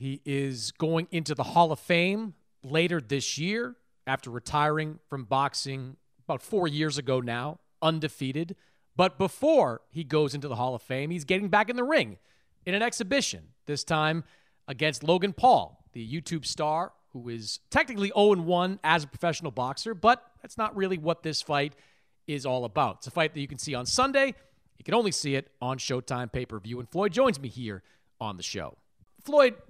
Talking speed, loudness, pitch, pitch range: 190 wpm, -28 LUFS, 155 Hz, 130-185 Hz